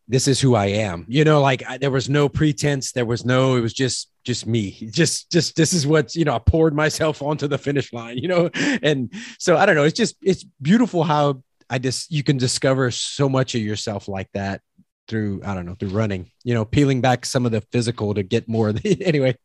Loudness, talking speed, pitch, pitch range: -20 LUFS, 245 wpm, 130 Hz, 115-150 Hz